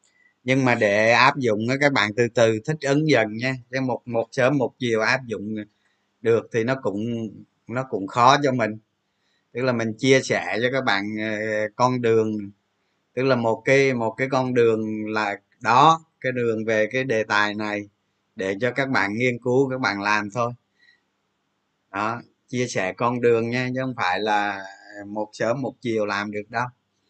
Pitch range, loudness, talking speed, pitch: 105-130 Hz, -22 LUFS, 190 wpm, 115 Hz